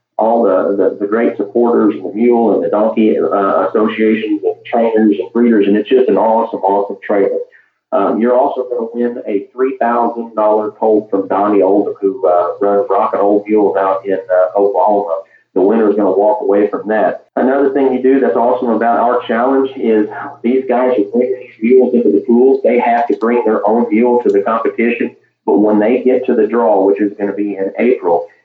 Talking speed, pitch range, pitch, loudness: 210 wpm, 100-125 Hz, 110 Hz, -13 LUFS